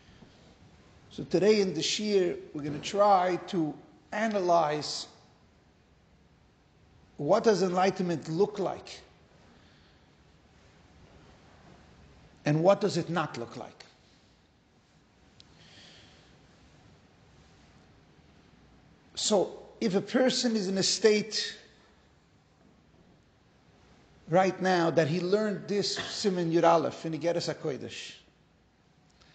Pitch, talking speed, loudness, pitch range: 170 Hz, 85 wpm, -28 LUFS, 145-200 Hz